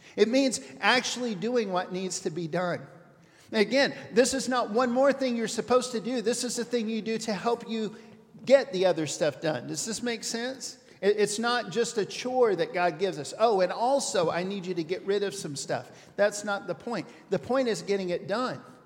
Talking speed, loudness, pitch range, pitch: 220 wpm, -28 LUFS, 180-240 Hz, 215 Hz